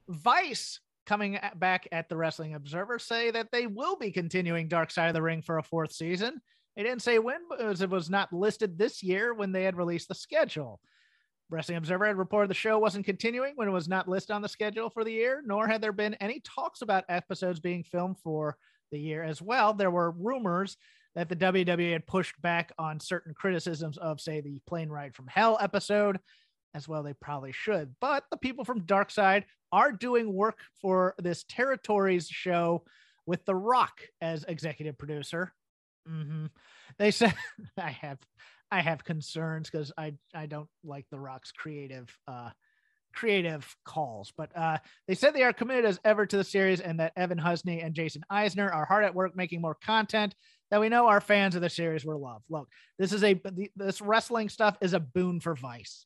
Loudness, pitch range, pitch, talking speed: -30 LUFS, 160-210 Hz, 185 Hz, 200 wpm